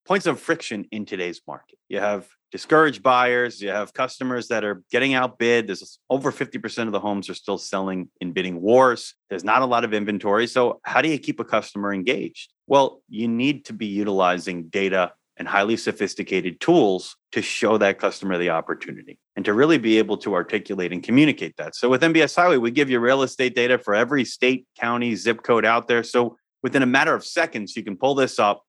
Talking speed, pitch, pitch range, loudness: 205 wpm, 115 Hz, 100-130 Hz, -21 LUFS